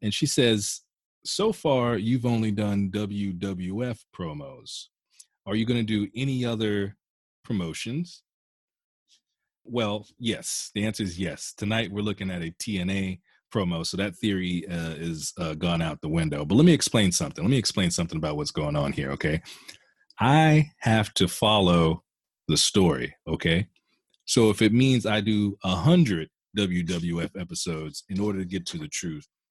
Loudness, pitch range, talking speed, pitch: -26 LUFS, 90-115 Hz, 165 wpm, 105 Hz